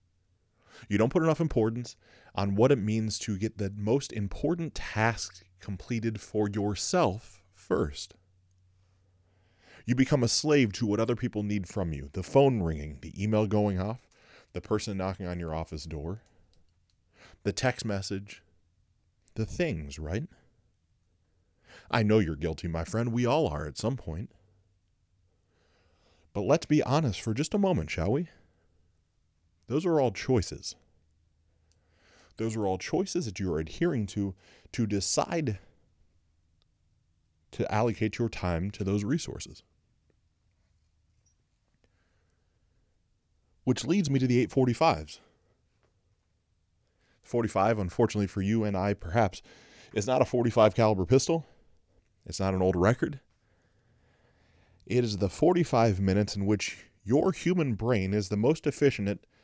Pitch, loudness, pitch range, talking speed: 100 Hz, -29 LUFS, 90-115 Hz, 135 wpm